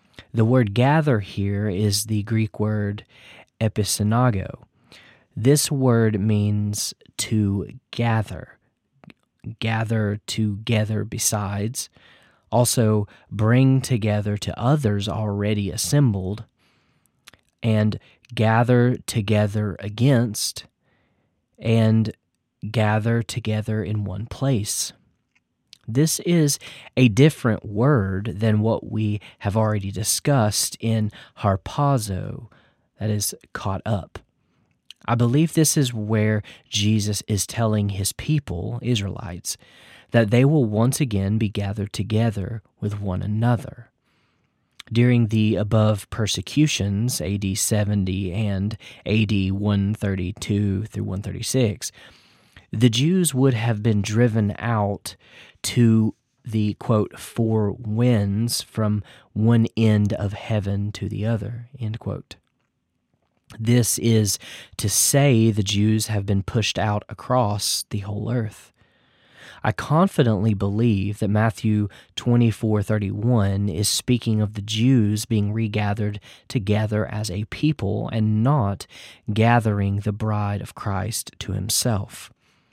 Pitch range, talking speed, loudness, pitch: 105-120 Hz, 105 wpm, -22 LUFS, 110 Hz